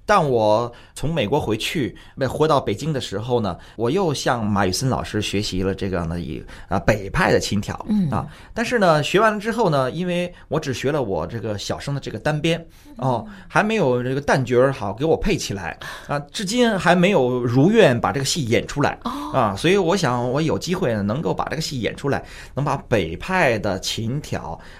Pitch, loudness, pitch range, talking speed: 125 Hz, -21 LUFS, 105-160 Hz, 285 characters per minute